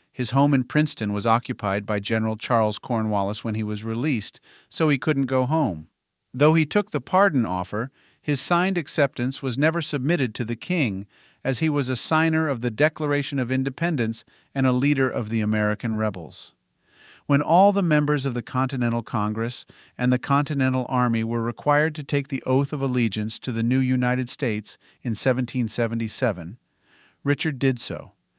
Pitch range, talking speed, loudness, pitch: 115-145 Hz, 170 wpm, -23 LUFS, 130 Hz